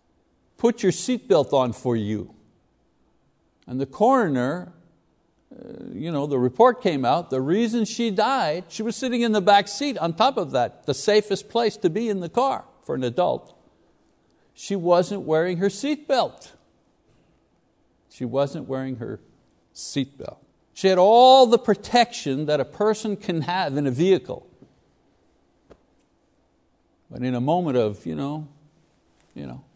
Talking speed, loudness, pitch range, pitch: 145 wpm, -22 LUFS, 135-220 Hz, 180 Hz